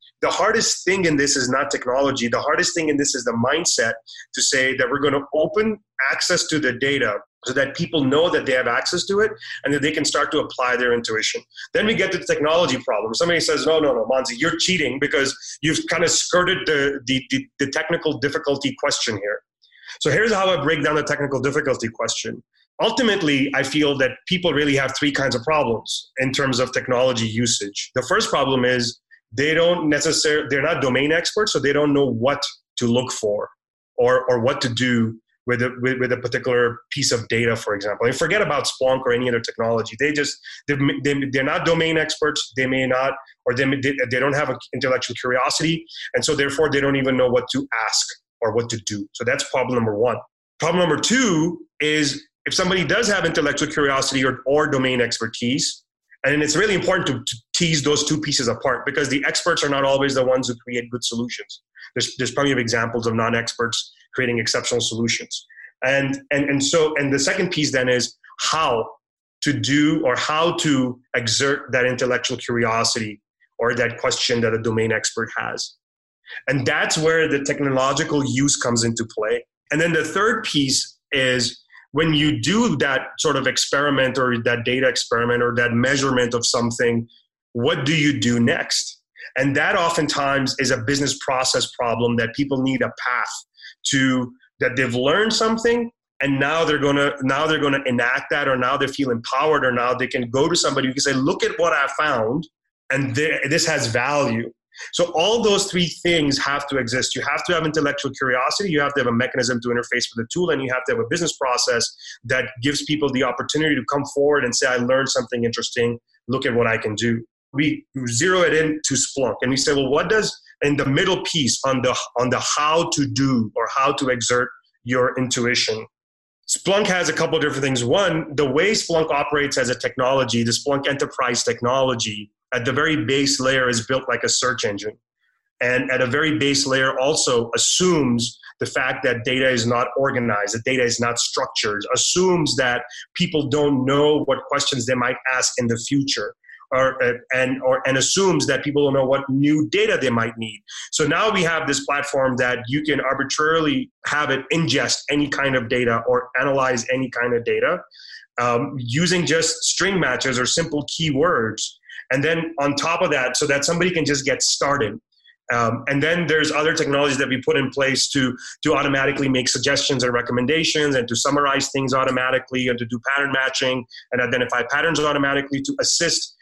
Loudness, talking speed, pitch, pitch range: -20 LUFS, 195 wpm, 140 Hz, 125-155 Hz